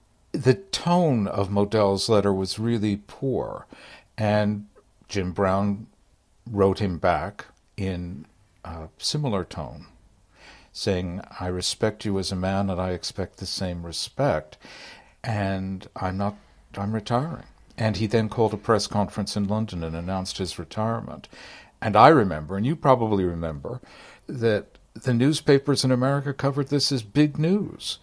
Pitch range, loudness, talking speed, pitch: 95-115 Hz, -24 LUFS, 140 wpm, 100 Hz